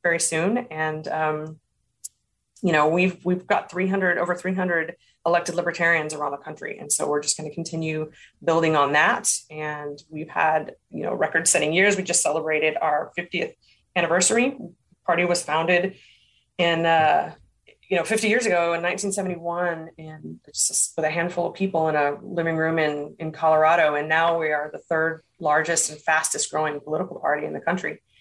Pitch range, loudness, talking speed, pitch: 155-175 Hz, -23 LUFS, 175 wpm, 165 Hz